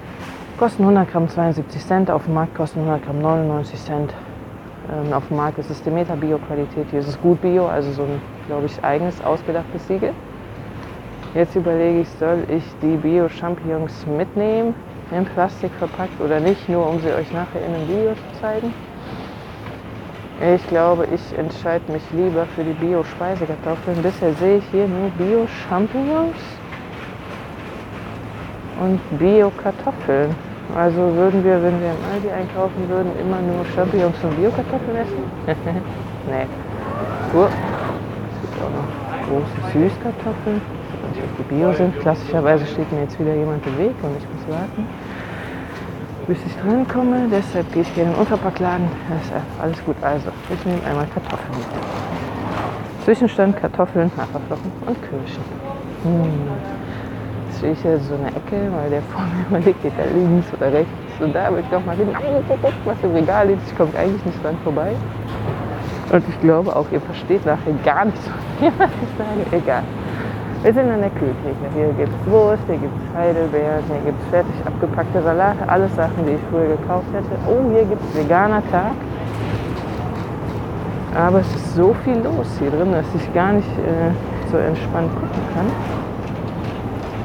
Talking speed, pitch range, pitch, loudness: 160 wpm, 145-185 Hz, 165 Hz, -20 LUFS